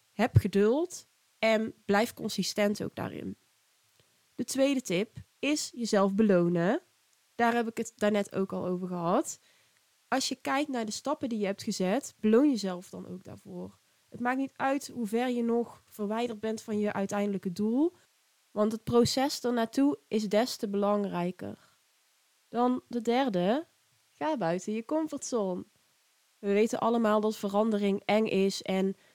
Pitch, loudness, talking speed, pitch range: 220 Hz, -30 LUFS, 155 wpm, 200-245 Hz